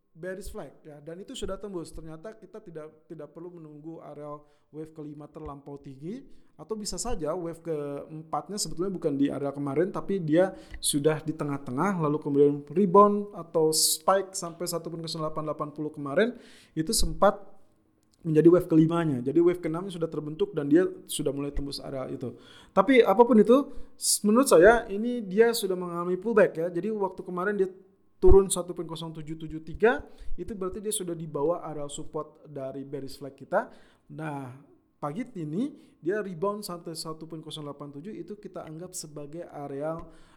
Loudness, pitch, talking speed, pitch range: -26 LUFS, 165 Hz, 145 wpm, 150-195 Hz